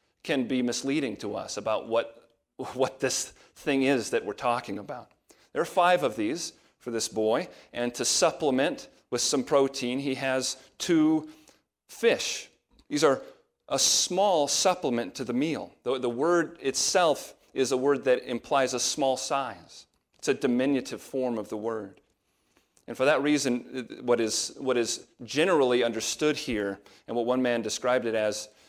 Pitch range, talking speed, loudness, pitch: 115-140 Hz, 165 wpm, -27 LUFS, 130 Hz